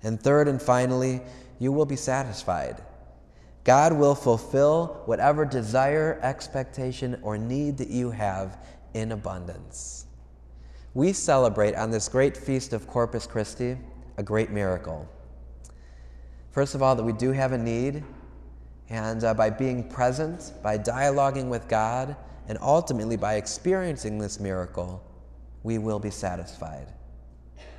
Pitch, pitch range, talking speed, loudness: 110 Hz, 85-130 Hz, 130 wpm, -26 LUFS